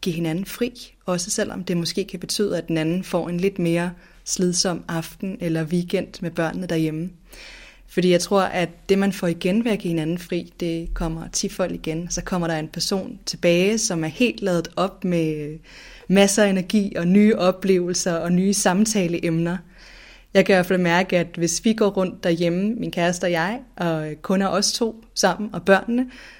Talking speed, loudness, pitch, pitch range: 195 wpm, -22 LUFS, 180 Hz, 170-195 Hz